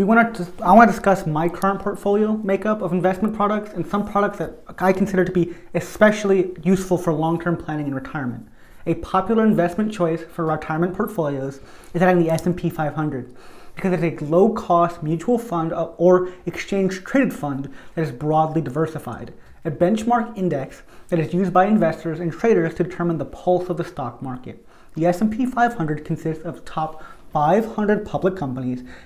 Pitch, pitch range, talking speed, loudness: 175 Hz, 160-195 Hz, 170 wpm, -21 LUFS